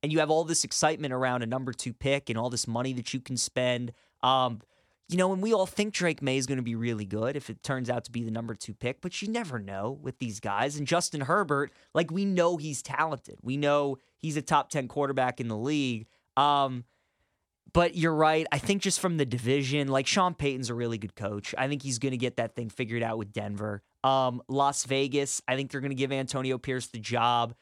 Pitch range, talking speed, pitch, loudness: 120-145 Hz, 240 wpm, 135 Hz, -29 LUFS